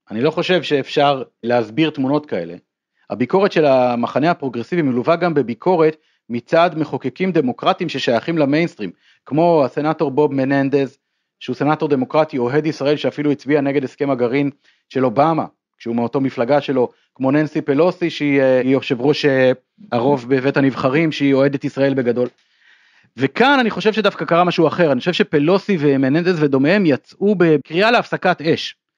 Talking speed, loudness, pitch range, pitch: 140 wpm, -17 LUFS, 135-165 Hz, 145 Hz